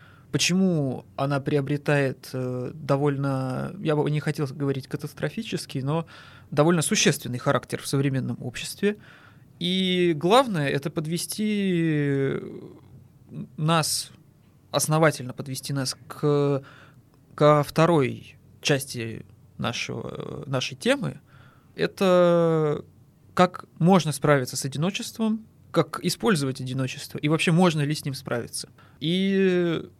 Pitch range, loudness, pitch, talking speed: 135-170 Hz, -25 LUFS, 150 Hz, 100 wpm